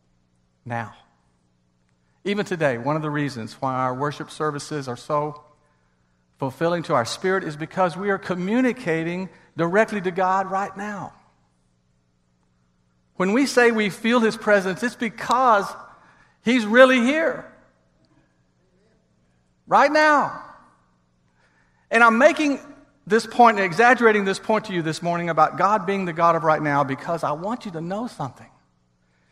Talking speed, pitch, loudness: 140 wpm, 160 Hz, -21 LUFS